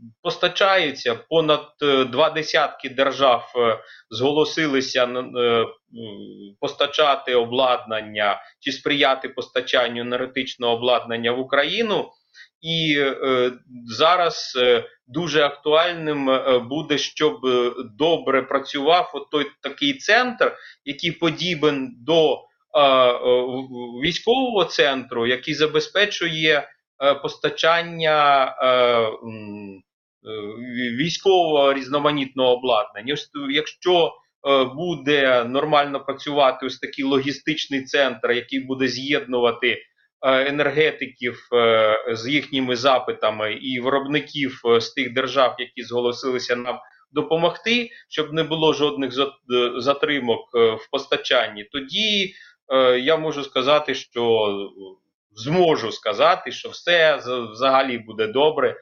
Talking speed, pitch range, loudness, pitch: 85 wpm, 125-155 Hz, -20 LUFS, 135 Hz